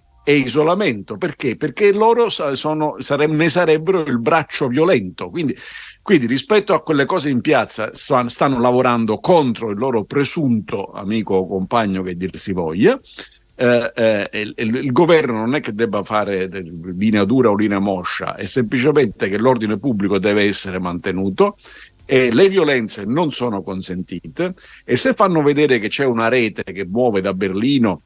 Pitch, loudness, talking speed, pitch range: 120 Hz, -17 LUFS, 165 wpm, 100-150 Hz